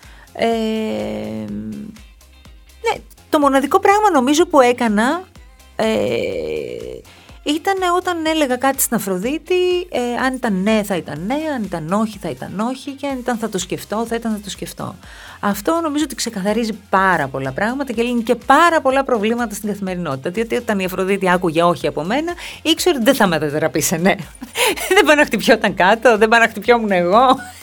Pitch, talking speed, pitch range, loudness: 230 Hz, 170 wpm, 190-290 Hz, -17 LUFS